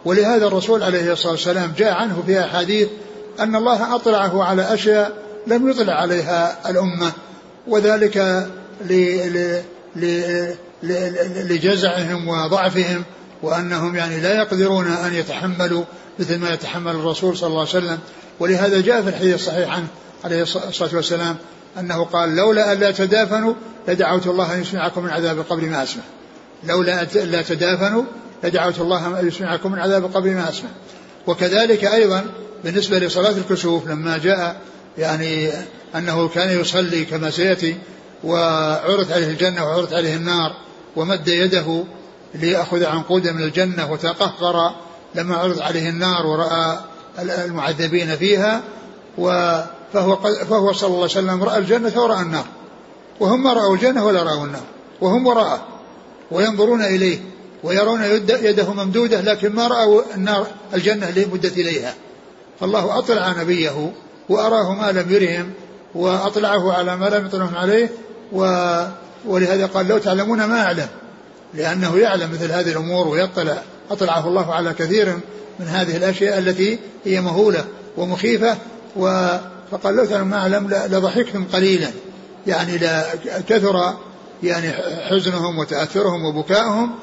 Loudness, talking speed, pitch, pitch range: -18 LUFS, 135 wpm, 185 Hz, 170-205 Hz